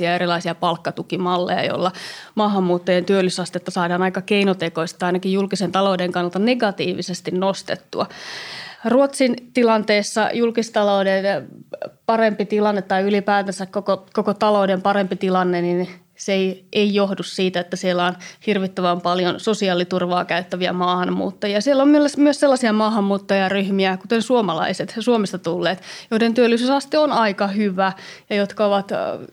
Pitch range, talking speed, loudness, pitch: 180-215 Hz, 120 wpm, -20 LUFS, 195 Hz